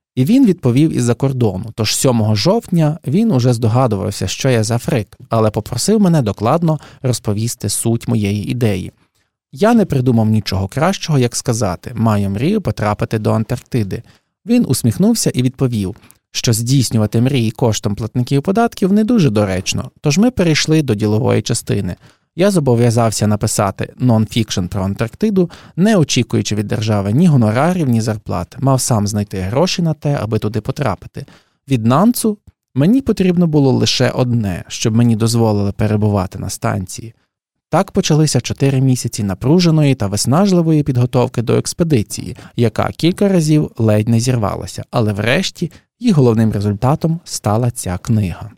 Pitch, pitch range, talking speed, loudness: 120 Hz, 110-150 Hz, 140 wpm, -15 LUFS